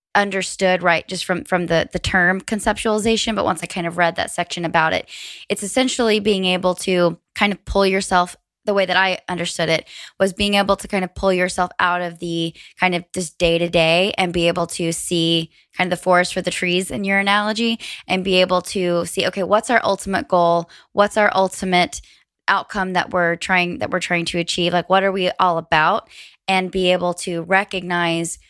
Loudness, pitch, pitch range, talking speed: -19 LUFS, 185 Hz, 175-195 Hz, 210 wpm